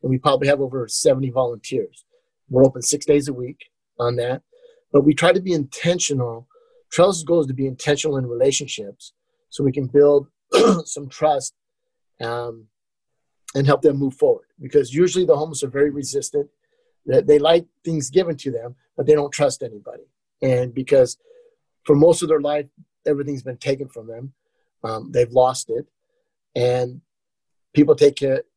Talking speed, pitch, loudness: 170 wpm, 145 Hz, -19 LUFS